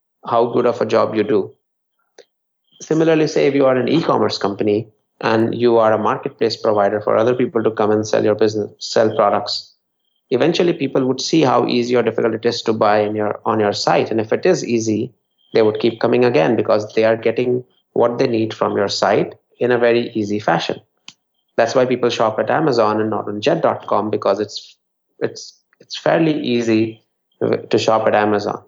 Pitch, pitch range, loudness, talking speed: 115 Hz, 105-125 Hz, -17 LUFS, 195 wpm